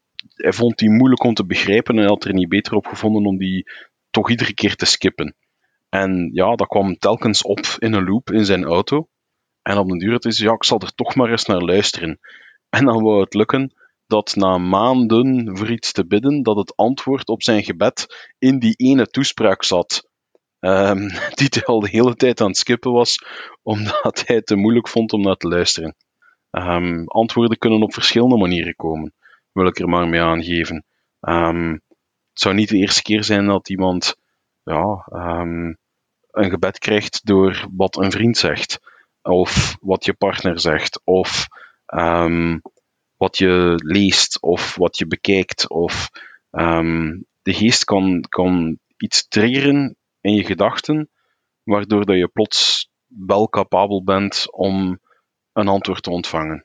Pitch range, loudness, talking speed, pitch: 90-115 Hz, -17 LUFS, 170 wpm, 100 Hz